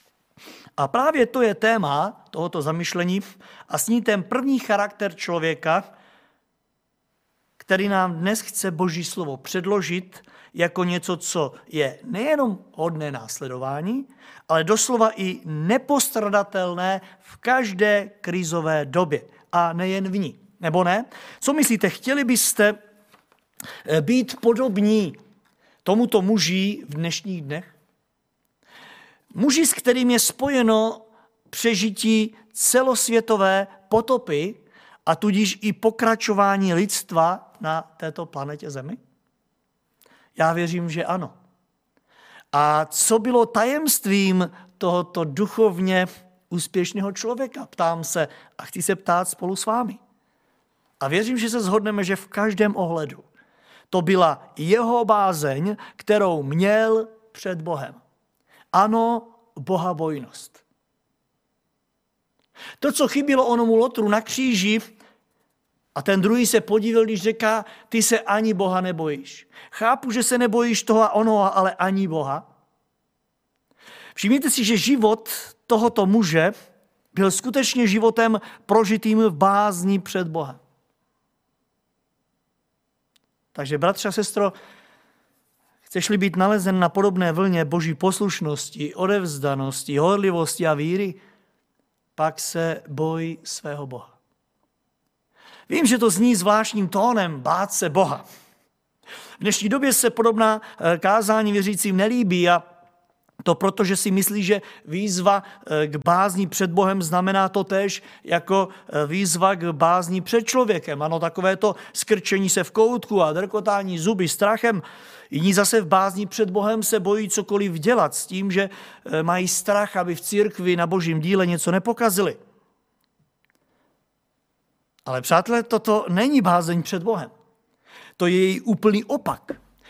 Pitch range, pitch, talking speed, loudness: 175-225 Hz, 200 Hz, 120 wpm, -21 LUFS